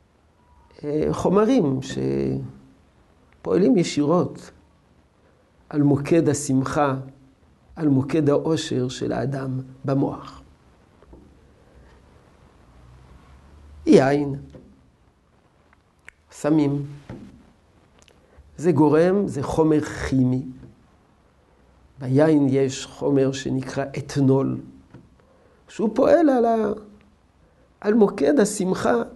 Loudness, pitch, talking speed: -21 LUFS, 130 Hz, 65 wpm